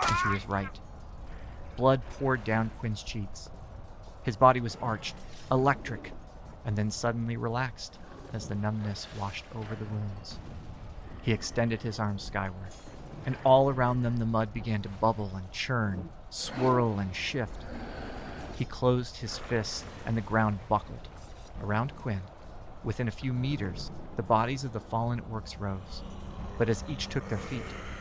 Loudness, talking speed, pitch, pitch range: -31 LUFS, 150 wpm, 110 Hz, 95-120 Hz